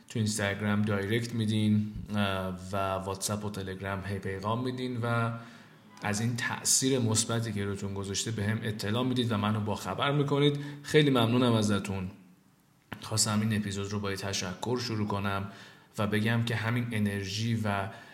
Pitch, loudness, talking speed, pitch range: 105 Hz, -30 LUFS, 150 wpm, 100-115 Hz